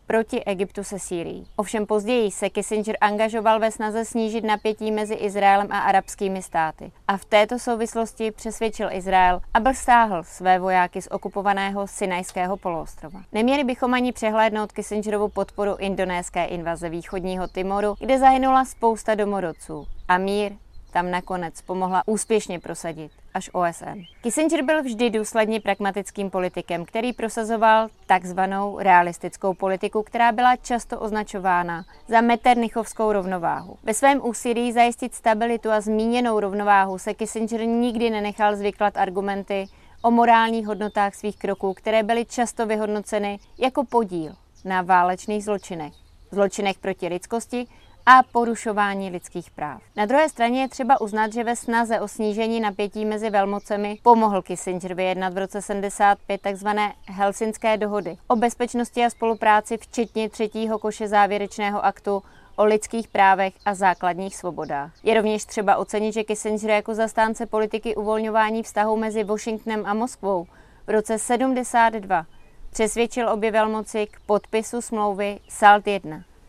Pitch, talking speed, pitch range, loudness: 210 Hz, 135 wpm, 195-225 Hz, -22 LUFS